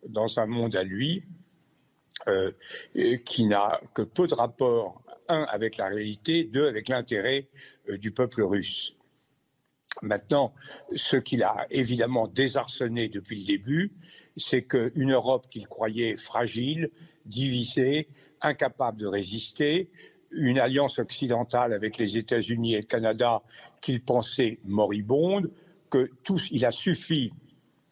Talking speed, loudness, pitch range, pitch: 125 wpm, -27 LUFS, 110-155 Hz, 130 Hz